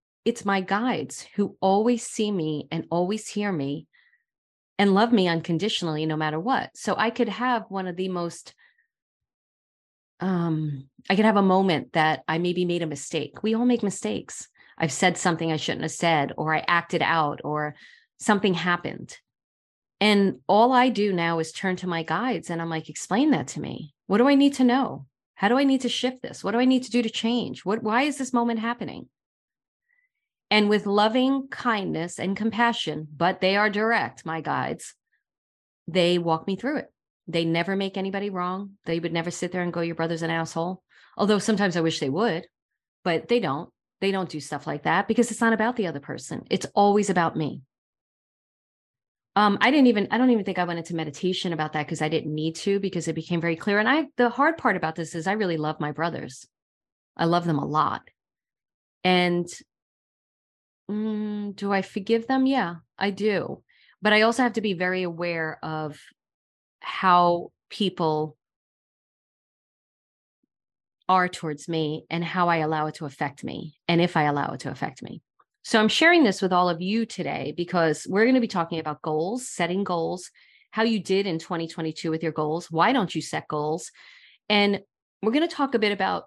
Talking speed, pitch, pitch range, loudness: 195 wpm, 180 Hz, 165-215 Hz, -24 LUFS